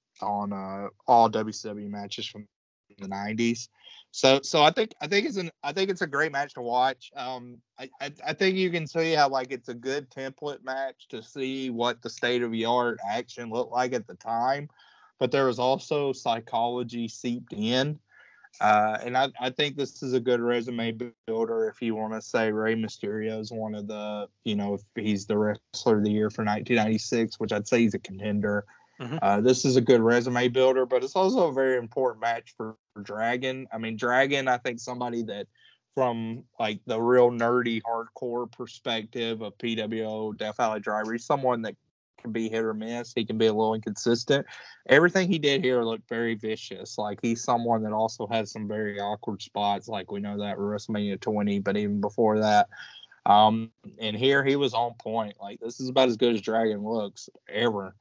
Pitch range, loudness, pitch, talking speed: 110-130 Hz, -27 LUFS, 115 Hz, 200 wpm